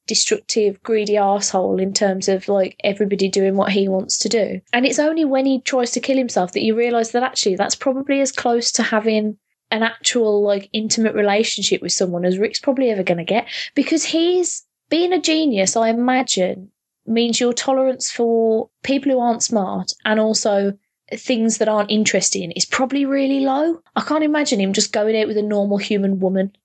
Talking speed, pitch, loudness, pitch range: 190 wpm, 220 Hz, -18 LUFS, 200-255 Hz